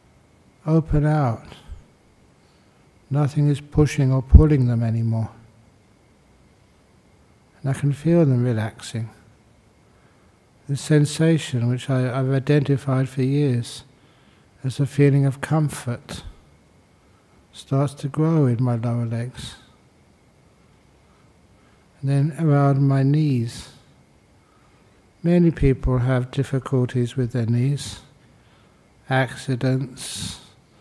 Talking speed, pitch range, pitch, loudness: 95 wpm, 115-140 Hz, 130 Hz, -21 LUFS